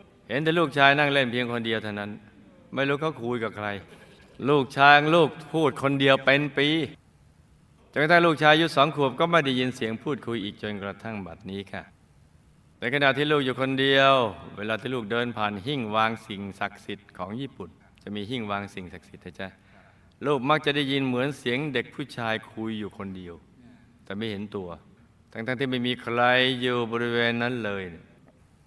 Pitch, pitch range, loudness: 120 Hz, 105-140 Hz, -24 LUFS